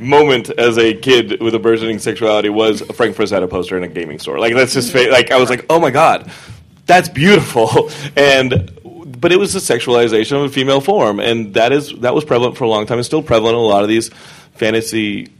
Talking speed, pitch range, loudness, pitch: 225 wpm, 110-145 Hz, -13 LUFS, 120 Hz